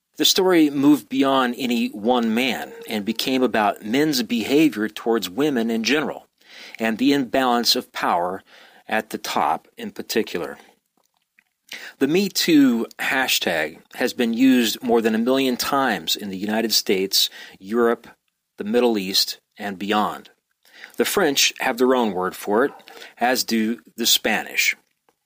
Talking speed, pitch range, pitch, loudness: 140 wpm, 110-150 Hz, 125 Hz, -20 LUFS